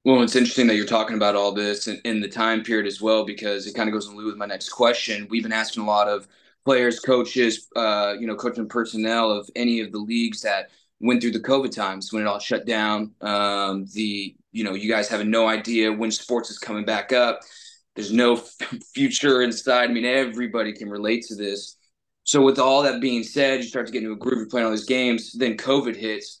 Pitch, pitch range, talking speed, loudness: 115 Hz, 105-125 Hz, 235 wpm, -22 LUFS